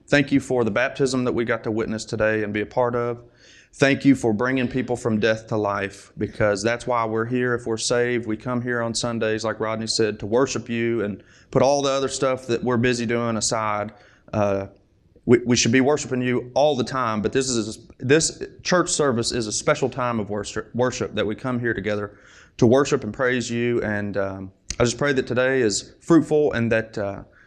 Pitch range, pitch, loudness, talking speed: 110-125 Hz, 120 Hz, -22 LUFS, 220 wpm